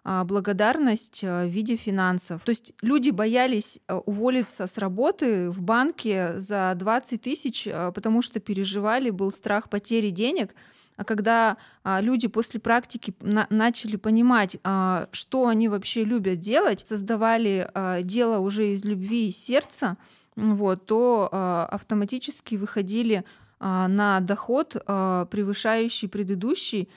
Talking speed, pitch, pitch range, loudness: 115 wpm, 215 Hz, 195-235 Hz, -25 LUFS